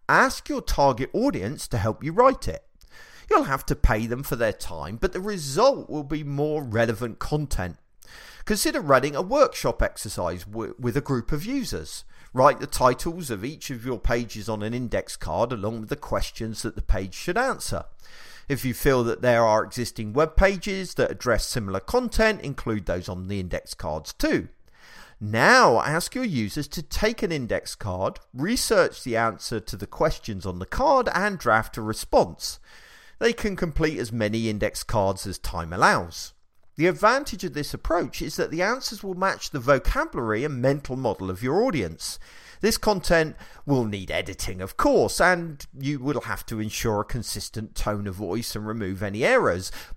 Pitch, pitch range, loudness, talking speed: 125 Hz, 105-155 Hz, -25 LUFS, 180 wpm